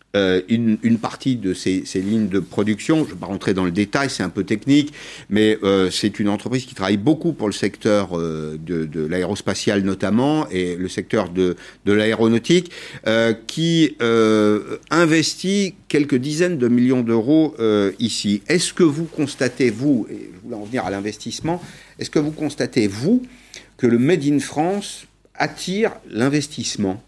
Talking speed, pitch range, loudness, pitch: 175 wpm, 100-150 Hz, -20 LUFS, 115 Hz